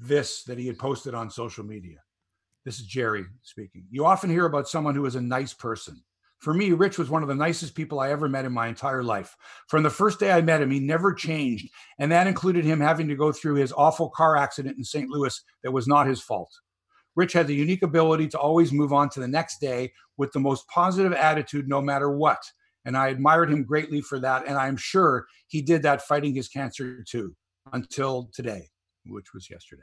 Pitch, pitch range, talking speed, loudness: 140 Hz, 130-160 Hz, 225 wpm, -24 LUFS